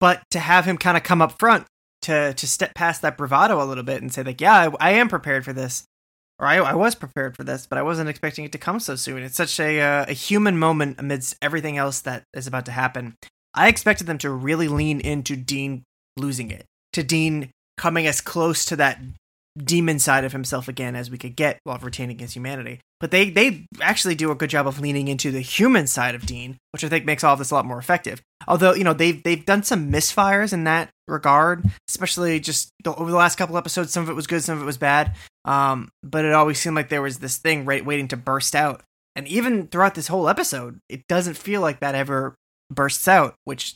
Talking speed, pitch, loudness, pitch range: 240 wpm, 150 Hz, -20 LUFS, 135-170 Hz